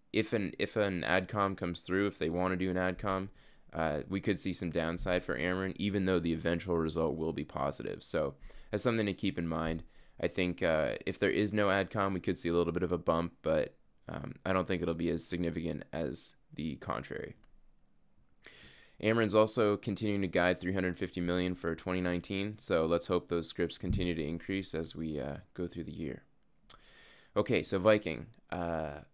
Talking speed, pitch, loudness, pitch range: 200 wpm, 90 Hz, -34 LUFS, 85-95 Hz